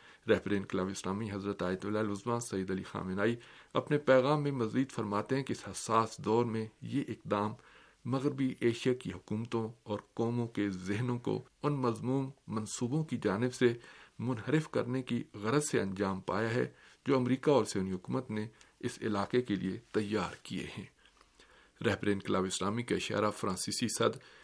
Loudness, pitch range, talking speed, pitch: -34 LUFS, 100-125 Hz, 155 wpm, 115 Hz